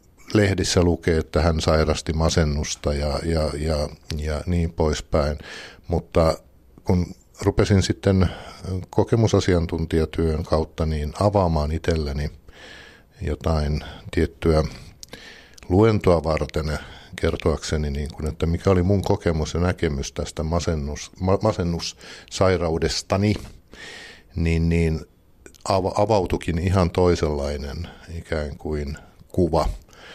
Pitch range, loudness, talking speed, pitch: 75-90 Hz, -23 LUFS, 90 wpm, 85 Hz